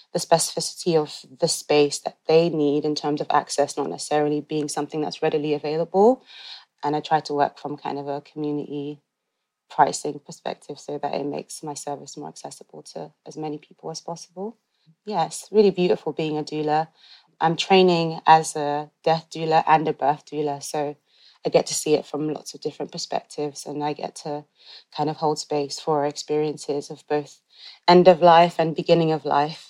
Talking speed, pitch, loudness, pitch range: 185 wpm, 150 Hz, -23 LUFS, 145-160 Hz